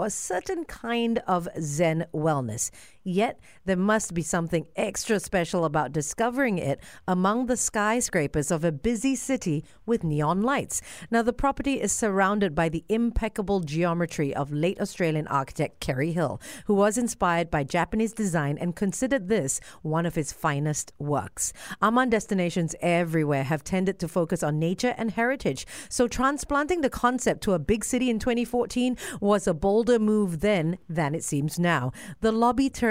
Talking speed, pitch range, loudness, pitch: 160 wpm, 165-230 Hz, -26 LUFS, 190 Hz